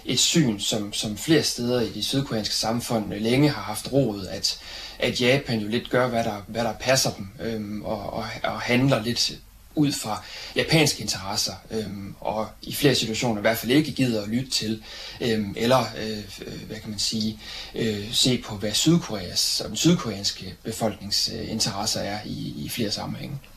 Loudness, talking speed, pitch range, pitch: -24 LUFS, 175 wpm, 105-125 Hz, 110 Hz